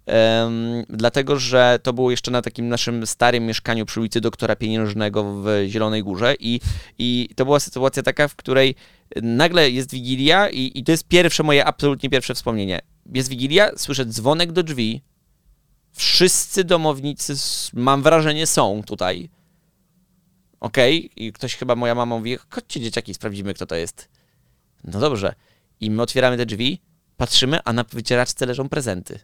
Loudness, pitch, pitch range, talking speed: -19 LUFS, 125 Hz, 115-145 Hz, 160 wpm